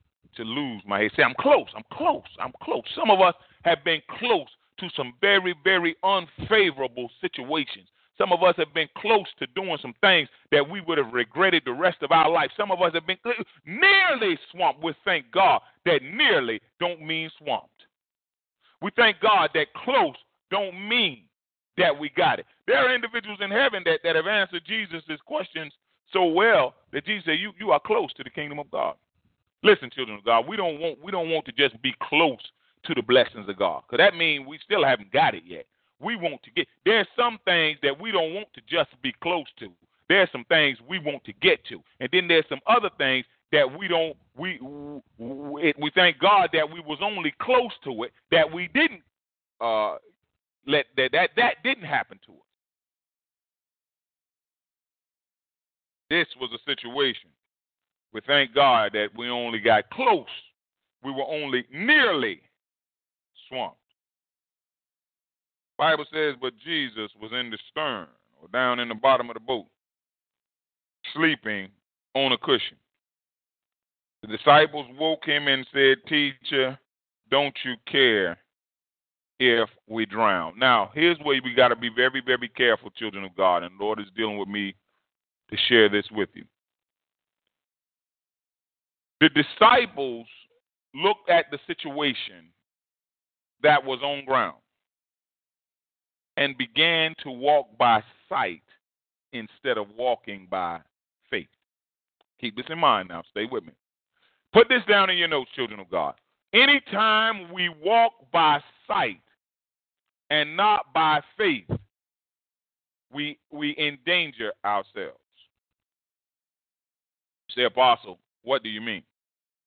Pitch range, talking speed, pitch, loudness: 125-185 Hz, 155 wpm, 150 Hz, -23 LUFS